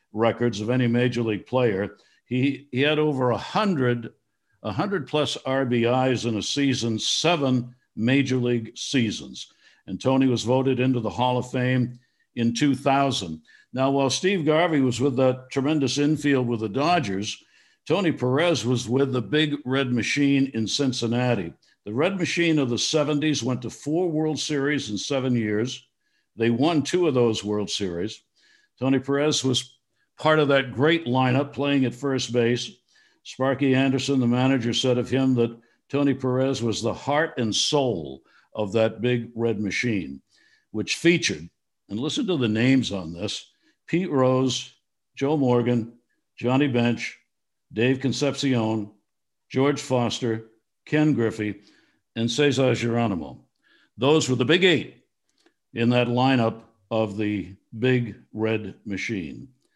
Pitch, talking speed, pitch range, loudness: 125 Hz, 145 wpm, 115-140 Hz, -23 LUFS